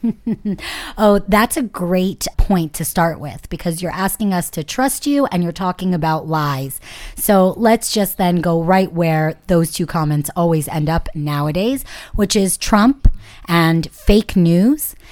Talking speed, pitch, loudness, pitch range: 160 wpm, 180 Hz, -17 LUFS, 165-210 Hz